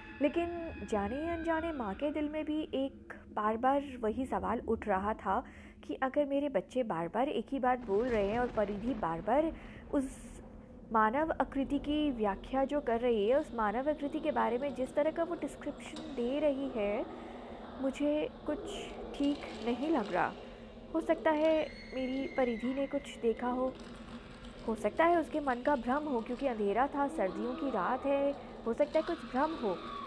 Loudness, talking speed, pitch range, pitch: -34 LUFS, 180 wpm, 235-295 Hz, 265 Hz